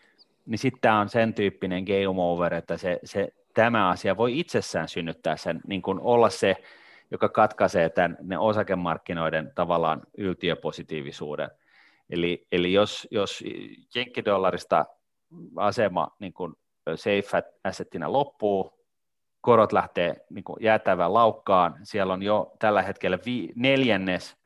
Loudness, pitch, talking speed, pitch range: -25 LUFS, 95 Hz, 120 wpm, 85-110 Hz